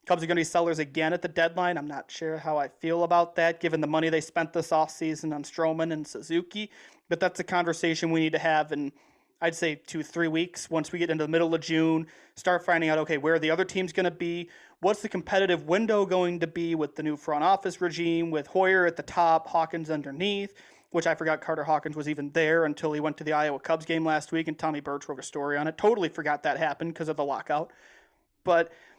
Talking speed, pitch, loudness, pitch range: 245 wpm, 165 Hz, -28 LUFS, 155-175 Hz